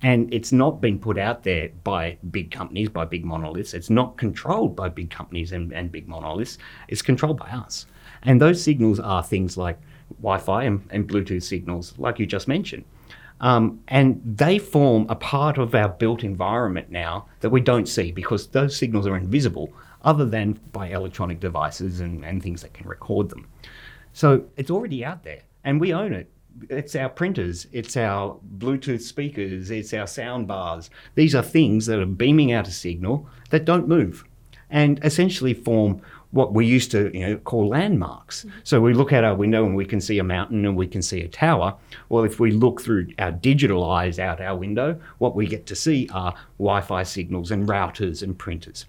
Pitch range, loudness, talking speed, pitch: 95-130 Hz, -22 LUFS, 195 wpm, 110 Hz